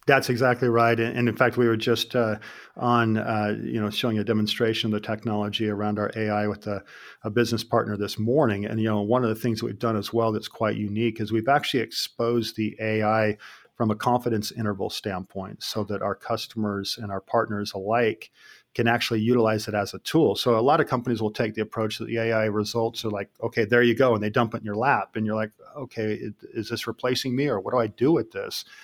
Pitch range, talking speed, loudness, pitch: 105-120 Hz, 235 wpm, -25 LUFS, 110 Hz